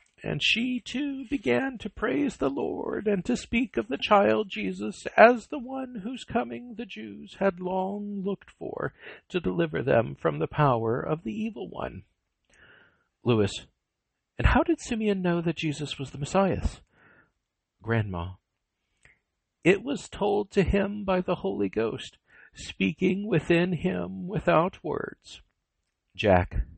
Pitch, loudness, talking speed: 180 Hz, -27 LUFS, 140 wpm